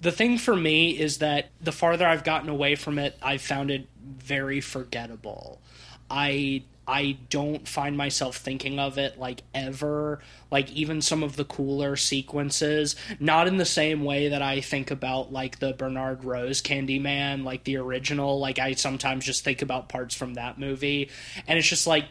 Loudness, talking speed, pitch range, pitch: -26 LUFS, 180 wpm, 130-150 Hz, 140 Hz